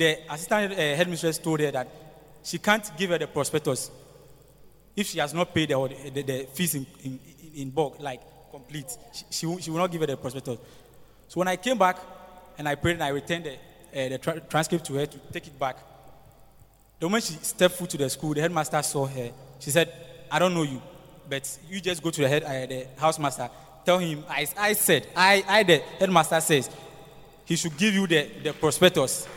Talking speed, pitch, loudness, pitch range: 215 wpm, 160 Hz, -26 LUFS, 140-175 Hz